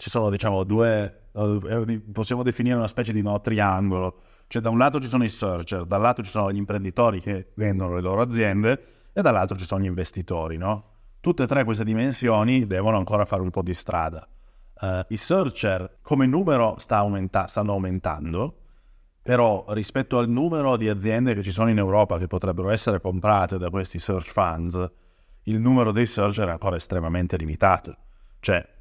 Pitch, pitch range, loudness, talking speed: 105 Hz, 95-115 Hz, -24 LUFS, 180 wpm